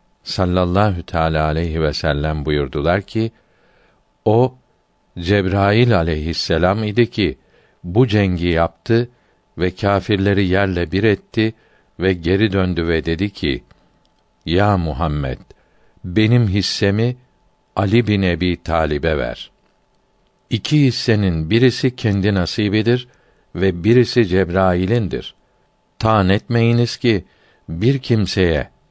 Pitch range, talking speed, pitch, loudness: 85-115 Hz, 100 wpm, 100 Hz, -18 LUFS